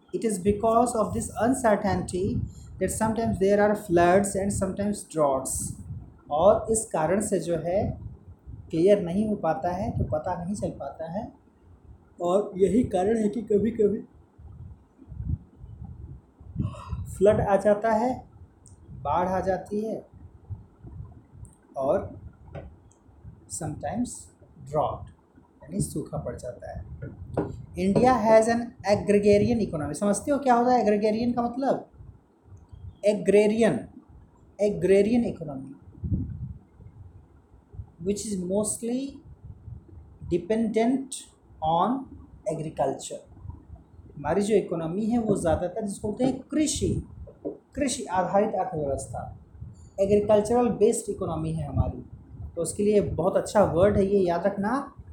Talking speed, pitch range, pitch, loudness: 110 wpm, 155-220 Hz, 200 Hz, -26 LUFS